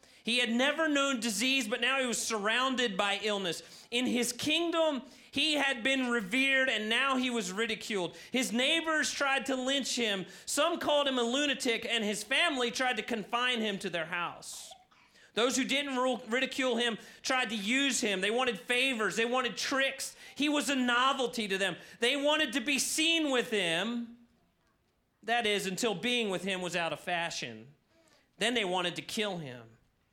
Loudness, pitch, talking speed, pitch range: -30 LUFS, 245 Hz, 175 wpm, 210-270 Hz